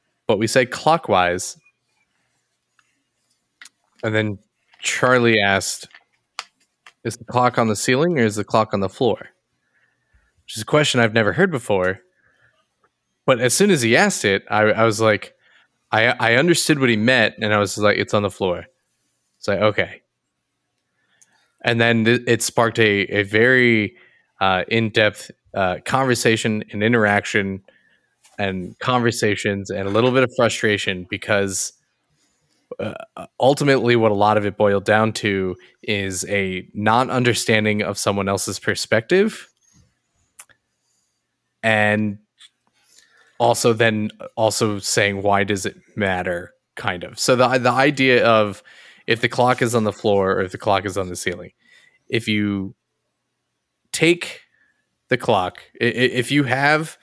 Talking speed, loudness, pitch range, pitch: 145 wpm, -19 LUFS, 100-125 Hz, 110 Hz